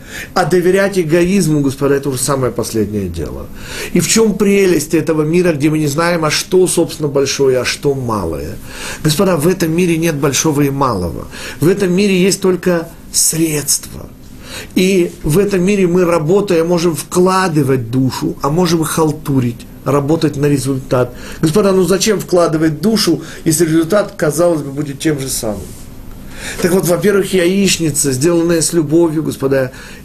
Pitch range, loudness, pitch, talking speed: 140-180 Hz, -13 LUFS, 160 Hz, 155 wpm